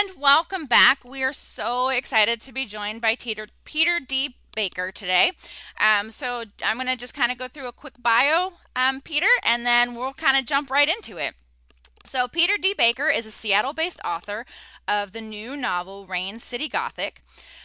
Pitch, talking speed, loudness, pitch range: 255 Hz, 180 wpm, -23 LUFS, 220-290 Hz